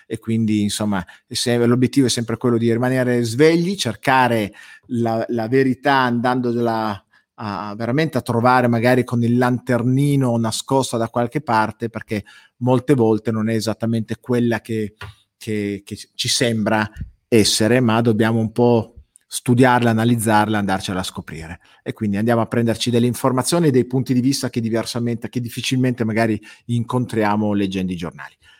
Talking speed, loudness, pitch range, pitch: 145 wpm, -19 LUFS, 110-125 Hz, 115 Hz